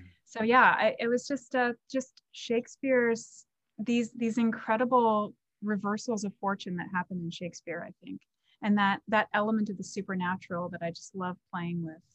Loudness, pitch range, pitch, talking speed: -30 LUFS, 180-235 Hz, 210 Hz, 170 wpm